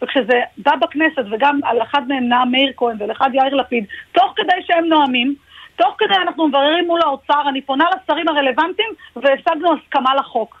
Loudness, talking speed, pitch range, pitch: -16 LUFS, 175 wpm, 265-335 Hz, 285 Hz